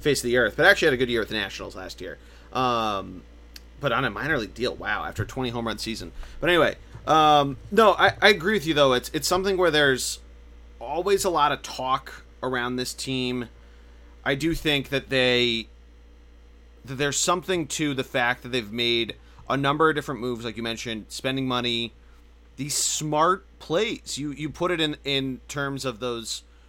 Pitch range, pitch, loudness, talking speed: 105-145 Hz, 125 Hz, -24 LUFS, 195 wpm